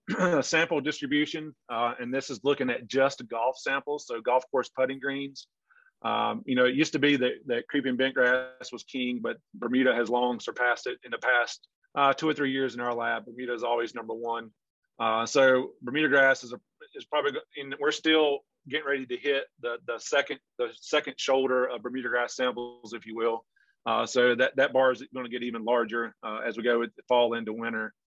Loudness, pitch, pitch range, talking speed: -28 LUFS, 130 Hz, 120-145 Hz, 215 wpm